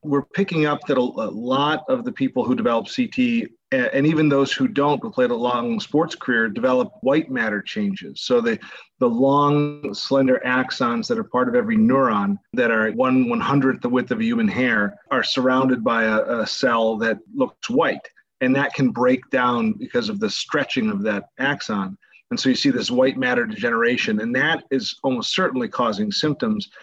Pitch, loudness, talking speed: 190 Hz, -21 LUFS, 195 wpm